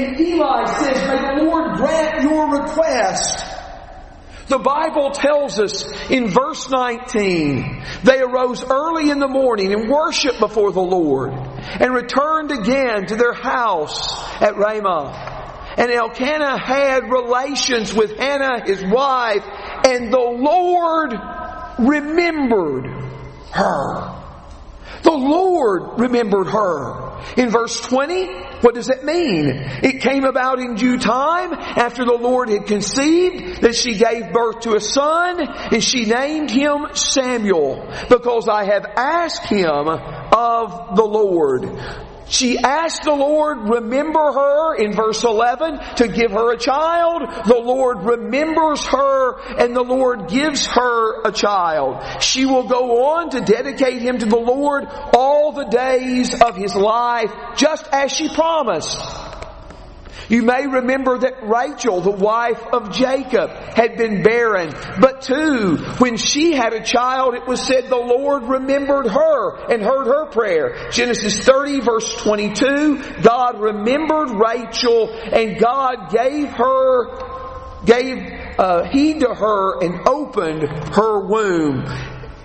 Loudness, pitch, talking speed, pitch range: -17 LUFS, 250 Hz, 135 wpm, 225-280 Hz